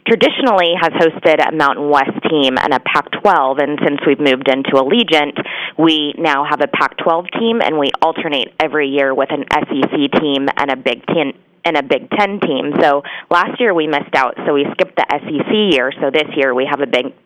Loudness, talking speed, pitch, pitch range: -14 LUFS, 205 wpm, 155 Hz, 140-180 Hz